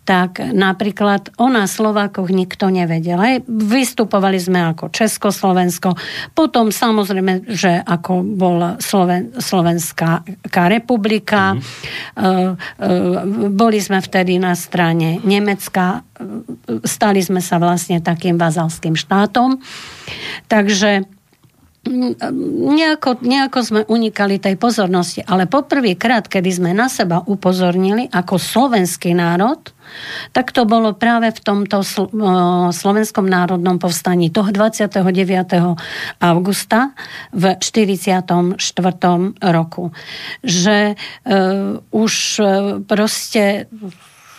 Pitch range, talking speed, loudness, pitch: 180-220 Hz, 90 wpm, -15 LUFS, 195 Hz